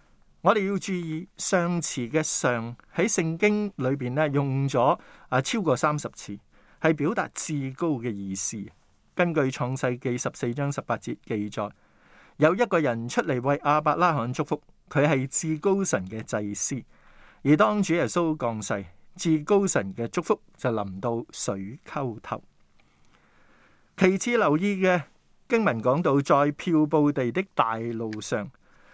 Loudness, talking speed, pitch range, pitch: -26 LUFS, 210 characters per minute, 115-175 Hz, 145 Hz